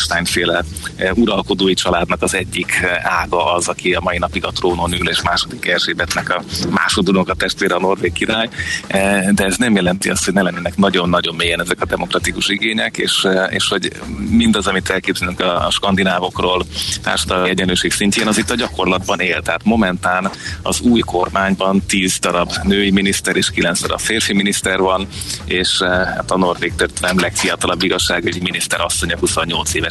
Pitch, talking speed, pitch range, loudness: 95 Hz, 165 wpm, 90-100 Hz, -16 LUFS